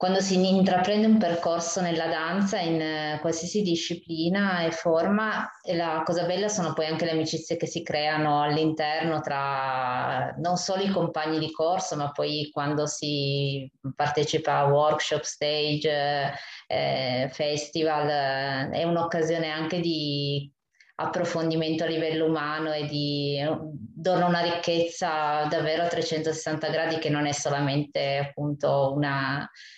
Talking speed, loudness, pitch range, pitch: 130 wpm, -26 LUFS, 145-170 Hz, 155 Hz